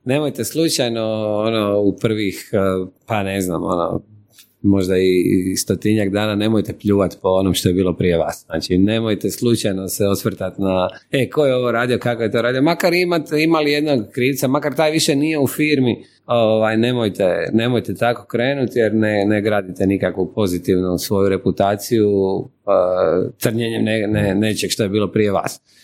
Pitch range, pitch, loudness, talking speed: 95-120 Hz, 110 Hz, -18 LUFS, 165 wpm